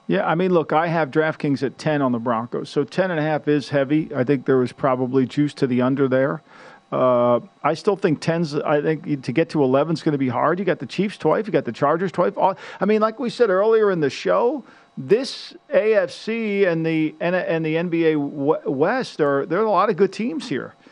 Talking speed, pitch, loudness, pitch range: 225 wpm, 155 Hz, -21 LUFS, 140-180 Hz